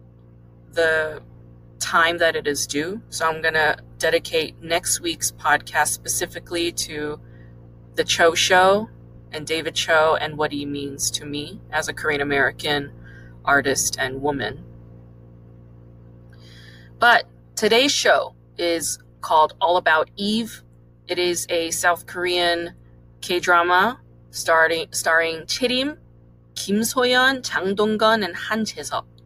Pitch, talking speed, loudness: 150 Hz, 120 wpm, -20 LUFS